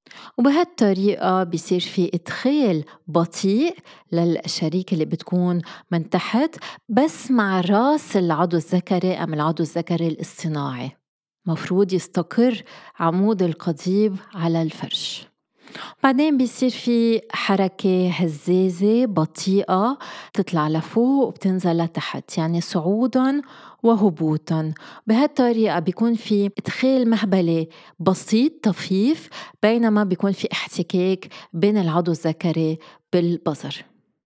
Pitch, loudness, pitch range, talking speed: 185 Hz, -21 LUFS, 170-225 Hz, 95 wpm